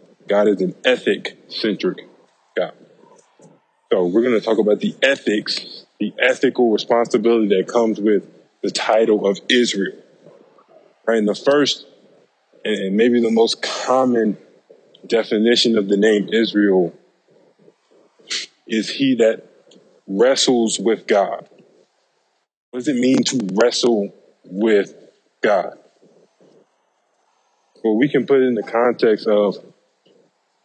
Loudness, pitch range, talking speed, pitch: -18 LUFS, 105-120 Hz, 115 wpm, 115 Hz